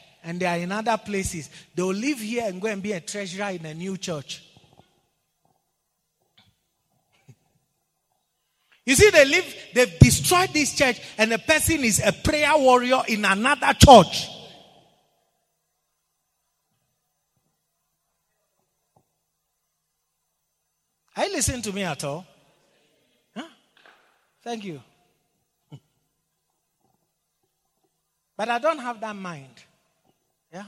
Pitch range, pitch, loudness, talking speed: 165-245 Hz, 195 Hz, -20 LUFS, 105 wpm